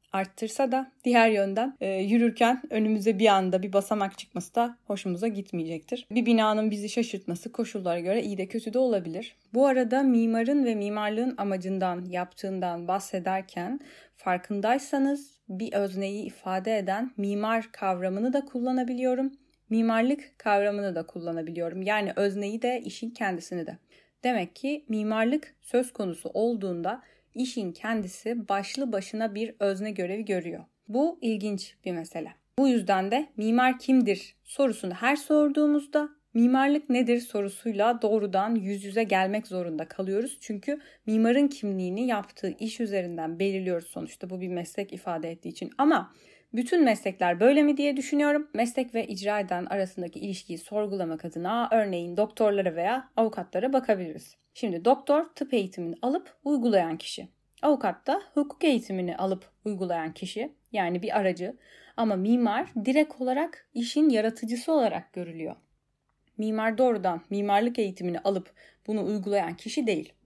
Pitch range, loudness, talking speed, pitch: 190-250 Hz, -28 LUFS, 135 wpm, 215 Hz